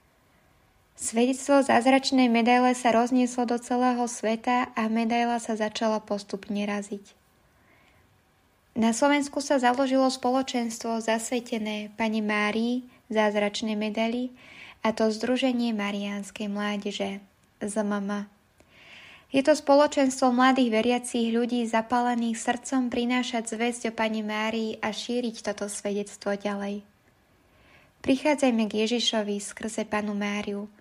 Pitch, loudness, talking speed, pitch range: 230 Hz, -26 LUFS, 105 wpm, 210-250 Hz